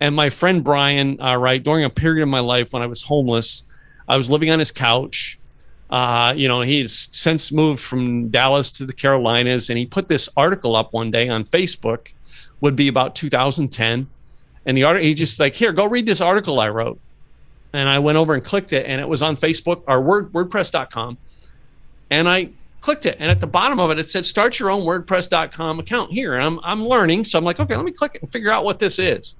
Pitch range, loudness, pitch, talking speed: 125-170 Hz, -18 LUFS, 145 Hz, 225 wpm